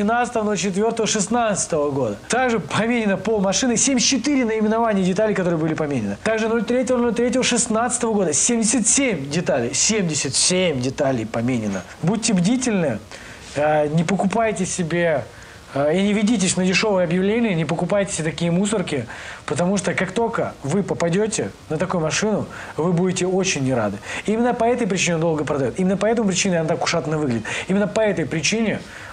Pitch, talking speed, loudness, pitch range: 190 Hz, 155 wpm, -20 LUFS, 160-225 Hz